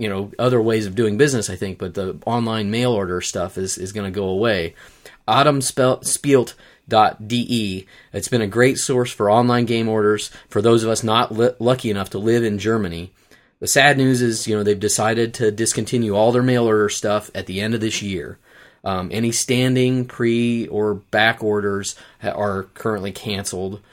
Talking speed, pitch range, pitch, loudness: 185 wpm, 100-120 Hz, 110 Hz, -19 LUFS